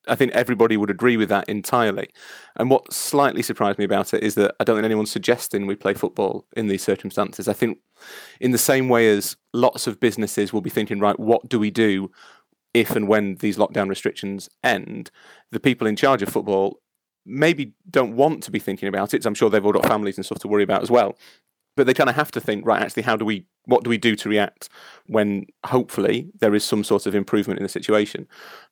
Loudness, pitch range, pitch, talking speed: -21 LUFS, 100-115 Hz, 105 Hz, 230 wpm